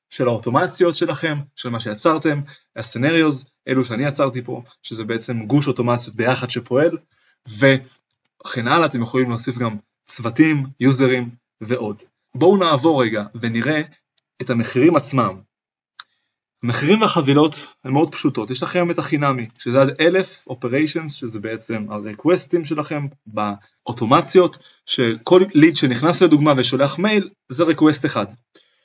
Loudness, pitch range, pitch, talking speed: -18 LUFS, 120-160 Hz, 135 Hz, 125 wpm